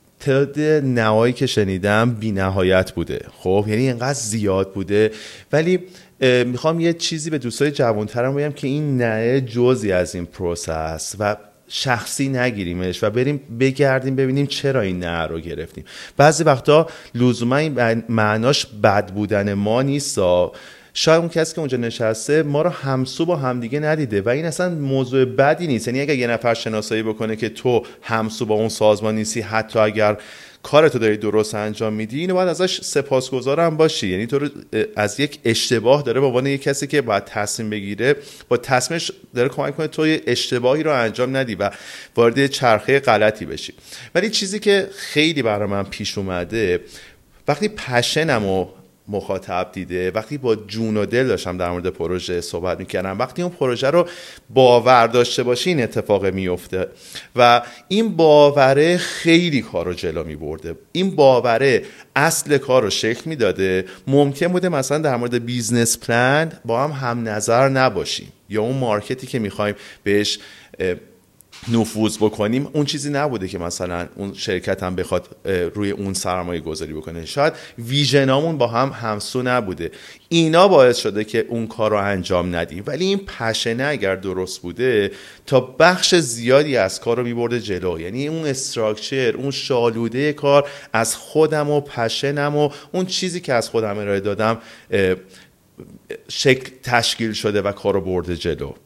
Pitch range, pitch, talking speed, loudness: 105-145 Hz, 120 Hz, 155 wpm, -19 LUFS